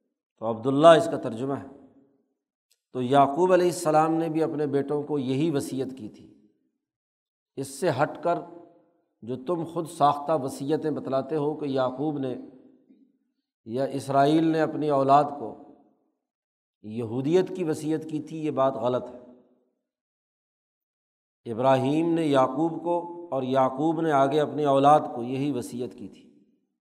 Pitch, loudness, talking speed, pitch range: 145 Hz, -25 LUFS, 140 wpm, 135-160 Hz